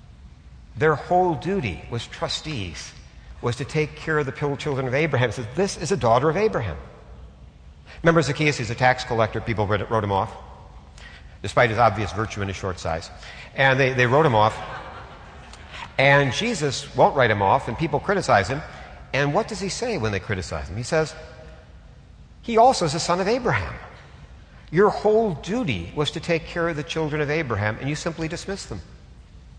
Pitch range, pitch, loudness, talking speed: 95-160 Hz, 125 Hz, -22 LUFS, 185 wpm